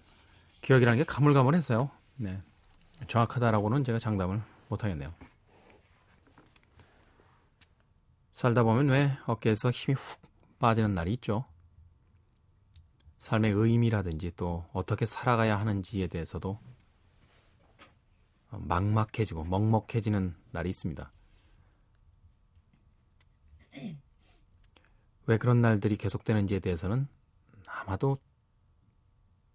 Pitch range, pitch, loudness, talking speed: 95-115 Hz, 105 Hz, -29 LUFS, 220 characters per minute